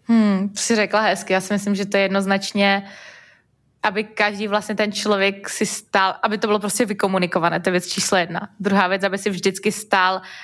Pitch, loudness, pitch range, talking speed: 200 Hz, -20 LUFS, 195-215 Hz, 195 wpm